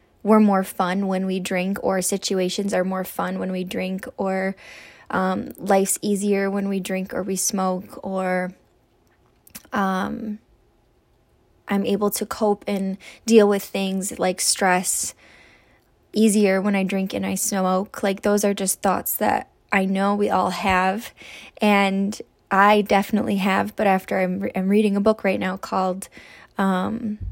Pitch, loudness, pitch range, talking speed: 195 Hz, -22 LUFS, 185-205 Hz, 155 wpm